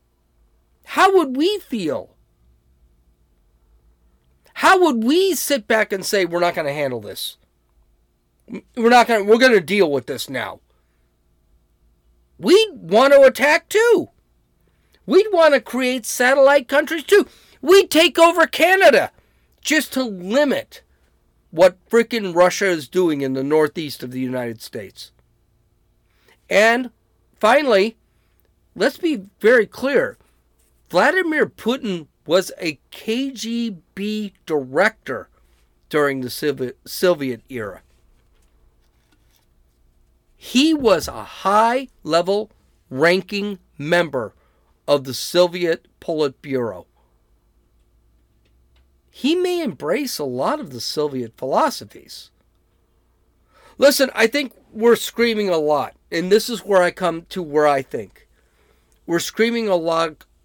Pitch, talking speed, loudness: 175 Hz, 110 wpm, -18 LUFS